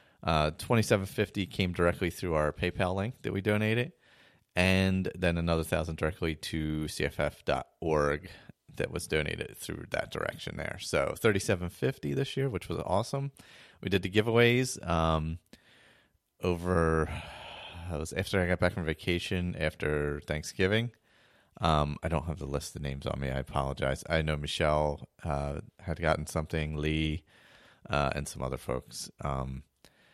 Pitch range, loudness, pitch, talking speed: 75-95 Hz, -31 LUFS, 80 Hz, 145 wpm